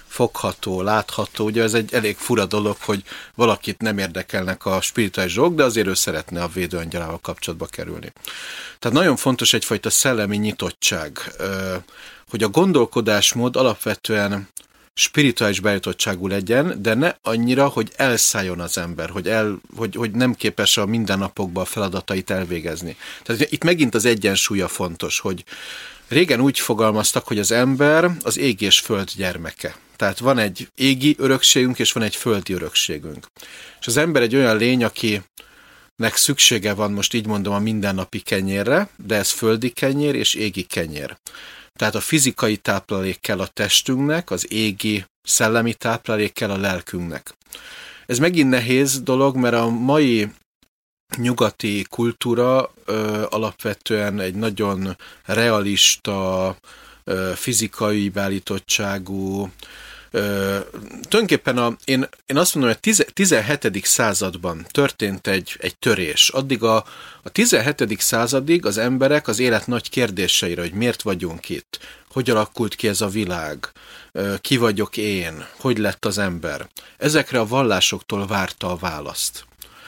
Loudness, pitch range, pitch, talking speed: -19 LUFS, 95-120 Hz, 105 Hz, 140 wpm